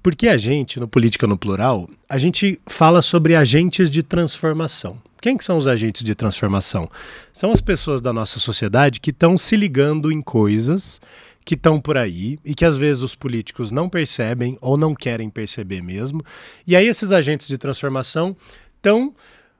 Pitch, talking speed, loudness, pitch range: 145 Hz, 175 wpm, -18 LUFS, 120-165 Hz